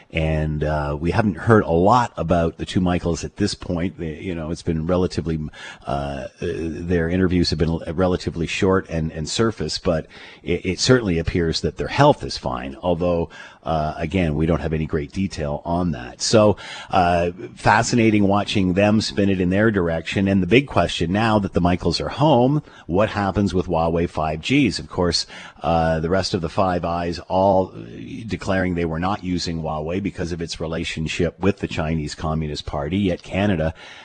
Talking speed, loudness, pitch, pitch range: 180 wpm, -21 LUFS, 85 Hz, 80-95 Hz